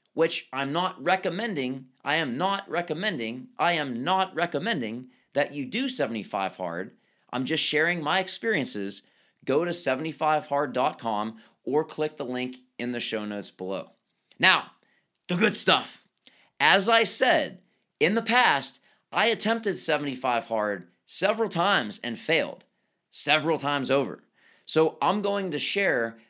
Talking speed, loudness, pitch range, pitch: 135 wpm, -26 LUFS, 130-200 Hz, 155 Hz